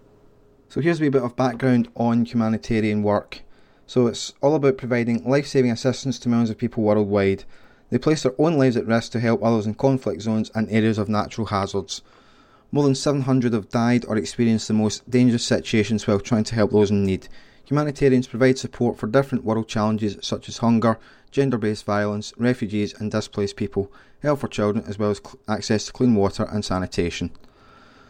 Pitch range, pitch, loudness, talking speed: 105-130 Hz, 115 Hz, -22 LUFS, 185 wpm